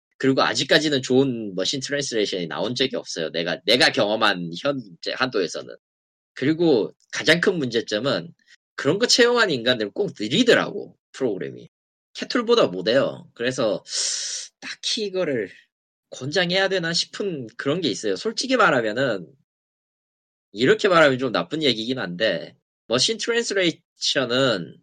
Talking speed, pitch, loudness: 310 characters per minute, 170 Hz, -22 LUFS